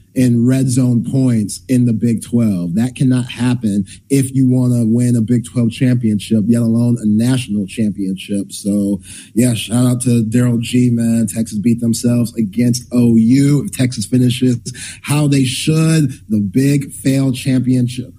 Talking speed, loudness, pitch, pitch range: 160 wpm, -15 LUFS, 120 Hz, 110-130 Hz